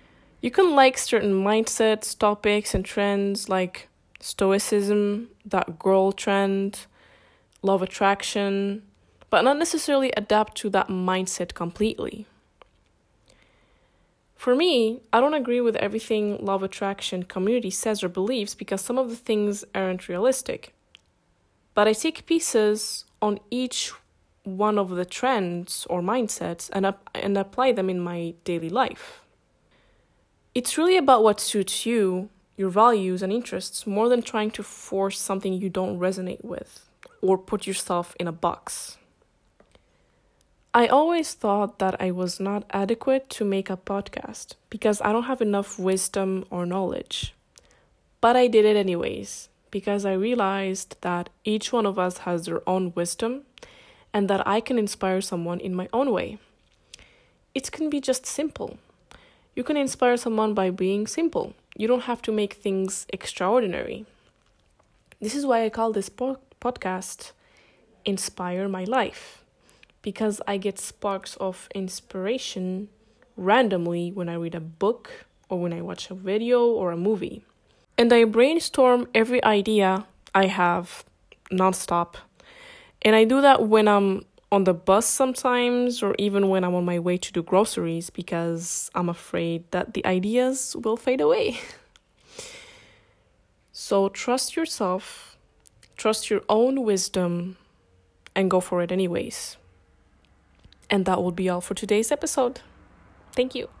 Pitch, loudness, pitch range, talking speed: 200 Hz, -24 LUFS, 185-235 Hz, 140 wpm